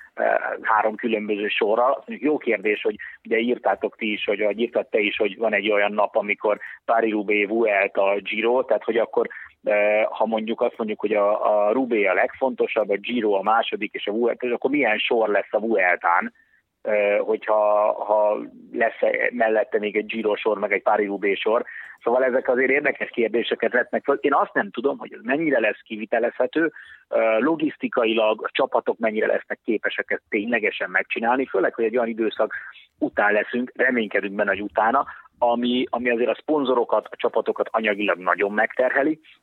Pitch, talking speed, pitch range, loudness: 110 Hz, 165 wpm, 105-120 Hz, -22 LUFS